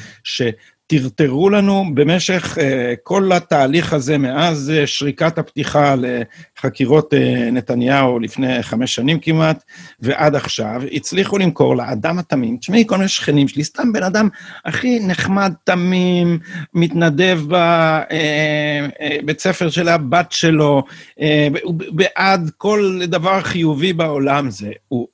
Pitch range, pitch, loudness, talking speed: 140-180 Hz, 155 Hz, -16 LUFS, 120 wpm